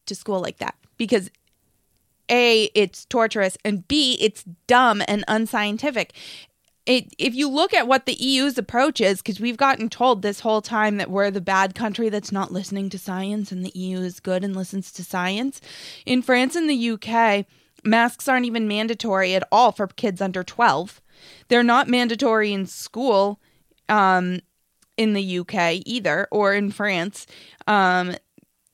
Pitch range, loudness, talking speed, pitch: 190-240 Hz, -21 LUFS, 165 wpm, 210 Hz